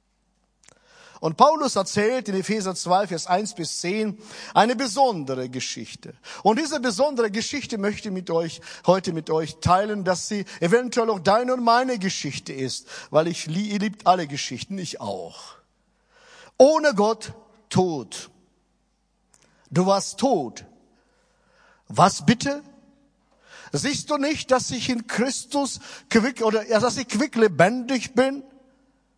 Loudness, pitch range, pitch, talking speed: -23 LUFS, 180-255 Hz, 220 Hz, 135 wpm